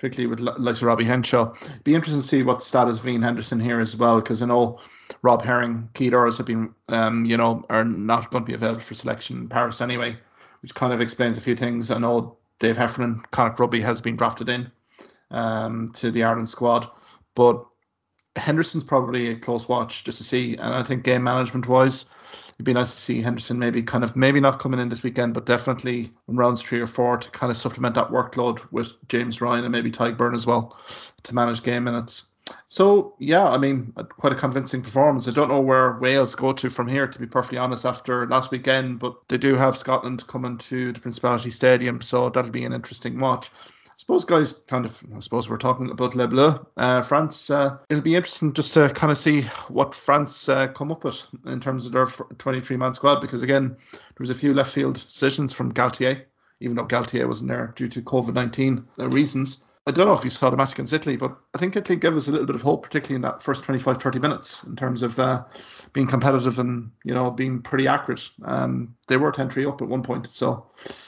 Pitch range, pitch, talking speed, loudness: 120-135 Hz, 125 Hz, 225 wpm, -22 LUFS